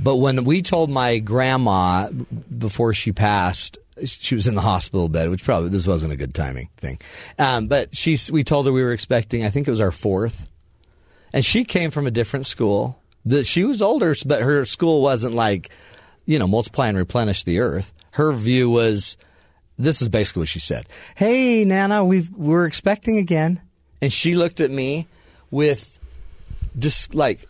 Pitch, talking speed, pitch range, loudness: 120 Hz, 185 wpm, 95-150 Hz, -20 LUFS